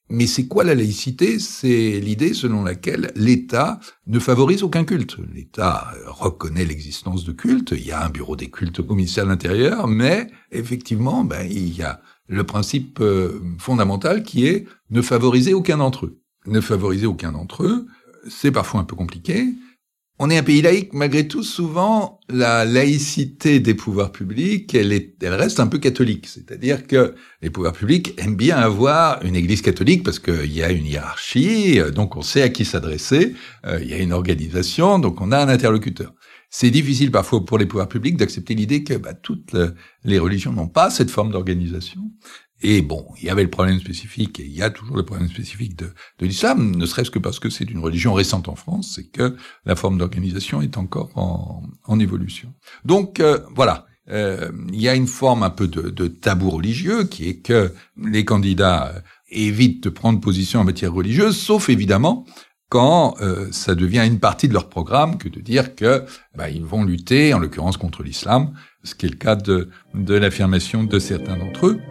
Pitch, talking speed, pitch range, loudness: 105 Hz, 195 wpm, 90-130 Hz, -19 LUFS